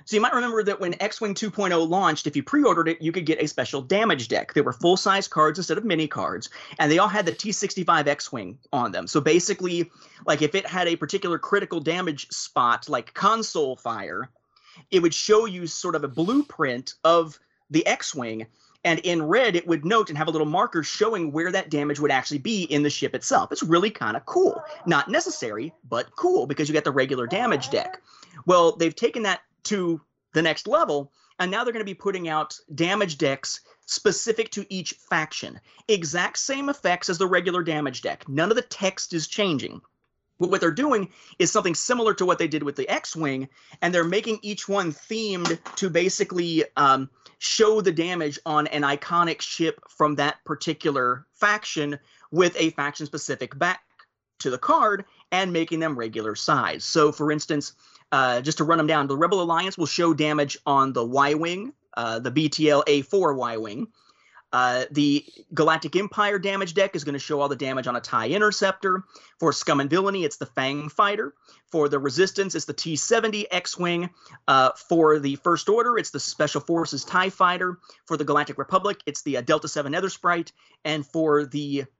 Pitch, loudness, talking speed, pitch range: 165 Hz, -24 LUFS, 190 wpm, 150-195 Hz